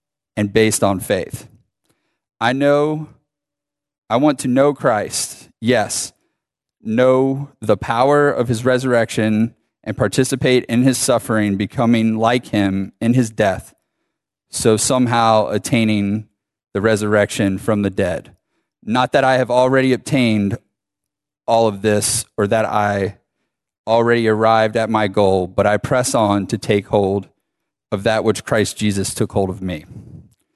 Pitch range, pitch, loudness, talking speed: 105-130 Hz, 110 Hz, -17 LUFS, 135 wpm